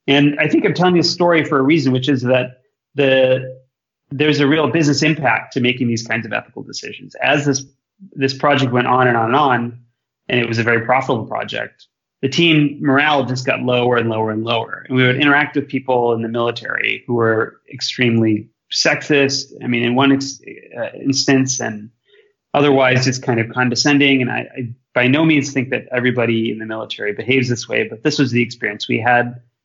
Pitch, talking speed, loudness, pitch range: 130 Hz, 205 wpm, -16 LUFS, 120-145 Hz